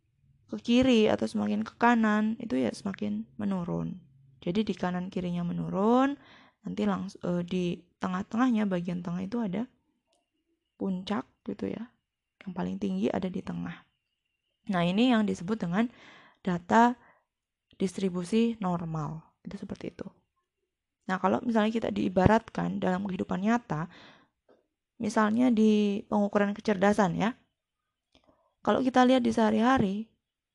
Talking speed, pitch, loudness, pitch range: 120 wpm, 210 Hz, -28 LUFS, 185-230 Hz